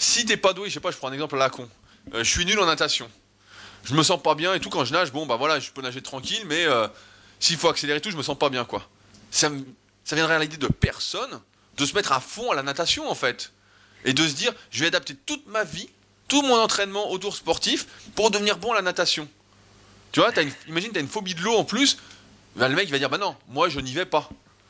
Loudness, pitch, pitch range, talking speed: -23 LUFS, 155 Hz, 130-200 Hz, 270 wpm